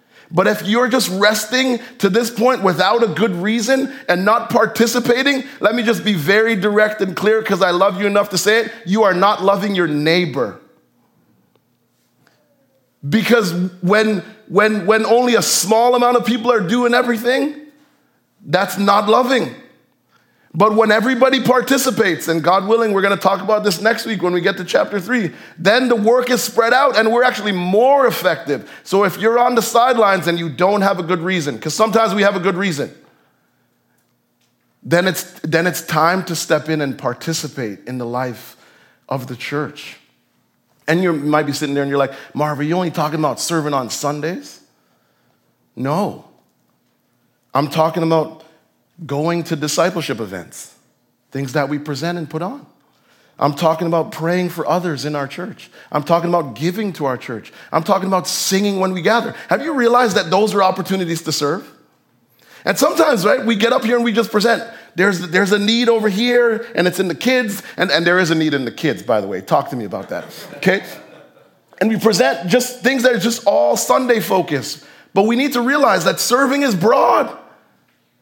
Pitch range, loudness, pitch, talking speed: 160-230 Hz, -16 LUFS, 195 Hz, 190 wpm